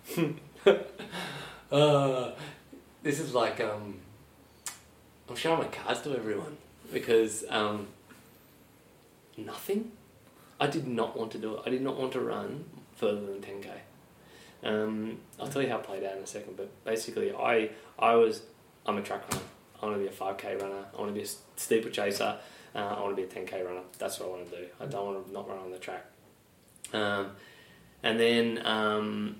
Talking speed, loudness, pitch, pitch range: 190 wpm, -32 LUFS, 110 Hz, 100-130 Hz